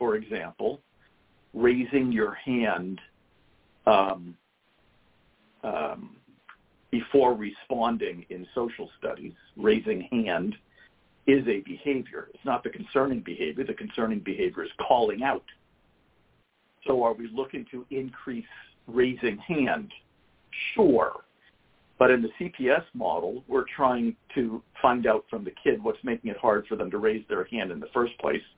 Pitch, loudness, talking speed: 125 Hz, -27 LUFS, 135 wpm